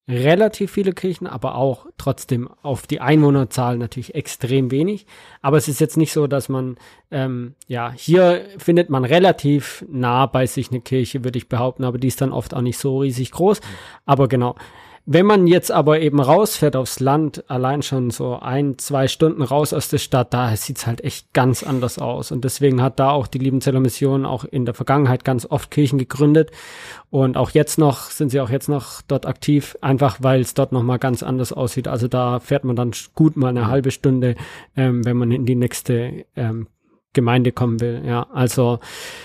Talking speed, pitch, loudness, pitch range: 195 wpm, 135 Hz, -19 LUFS, 125-145 Hz